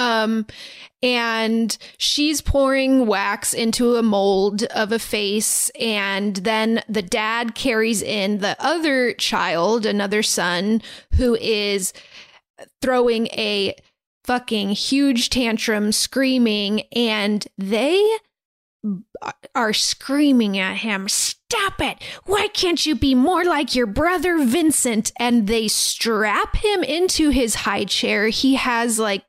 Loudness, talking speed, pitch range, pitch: -19 LUFS, 120 wpm, 210-265 Hz, 230 Hz